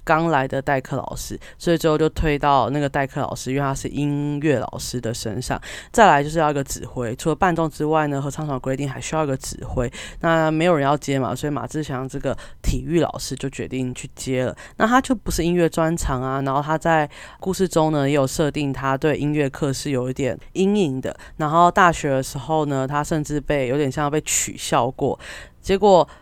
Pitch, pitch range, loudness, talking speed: 145 Hz, 135-155 Hz, -21 LUFS, 315 characters per minute